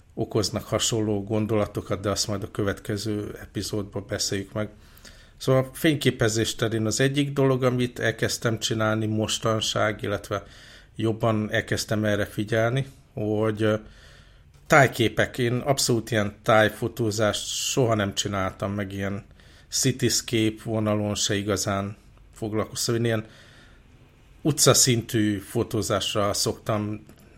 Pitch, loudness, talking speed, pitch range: 110 Hz, -25 LUFS, 105 wpm, 105-115 Hz